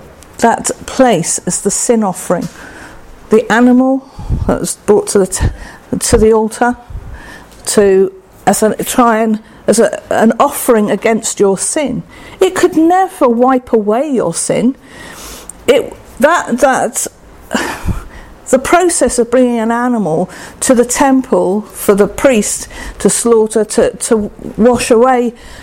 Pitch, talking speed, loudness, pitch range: 235 Hz, 135 wpm, -12 LUFS, 210-260 Hz